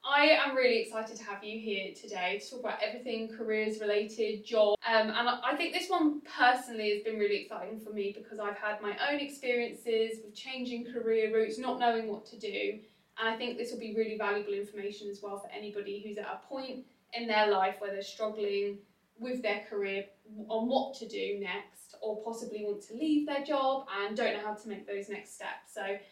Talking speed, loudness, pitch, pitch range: 210 wpm, -33 LUFS, 220 Hz, 205-245 Hz